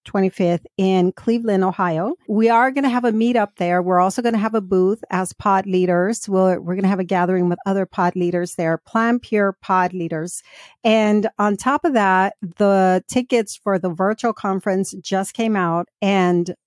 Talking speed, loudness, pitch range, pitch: 190 wpm, -19 LUFS, 180-220 Hz, 195 Hz